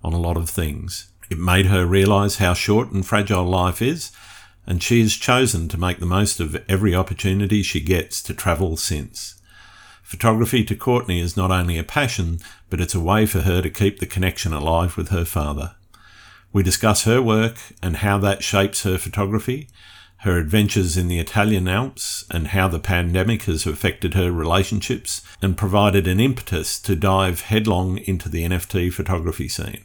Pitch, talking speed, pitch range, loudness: 95 Hz, 175 wpm, 90-105 Hz, -20 LUFS